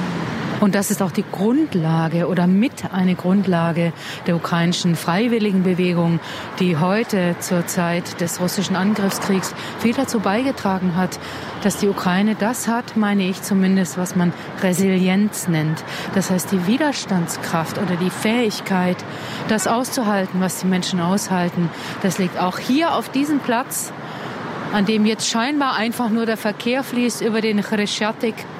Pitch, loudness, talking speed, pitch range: 195 Hz, -20 LUFS, 145 wpm, 180-220 Hz